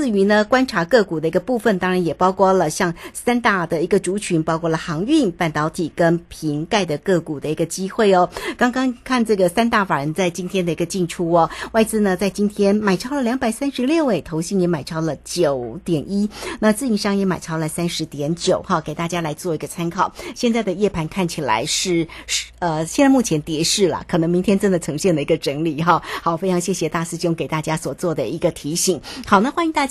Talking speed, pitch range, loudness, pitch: 330 characters per minute, 165-205 Hz, -19 LUFS, 180 Hz